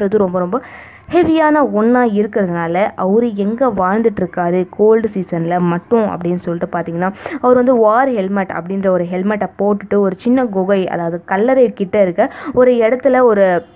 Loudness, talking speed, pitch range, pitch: -14 LUFS, 140 wpm, 180-240 Hz, 200 Hz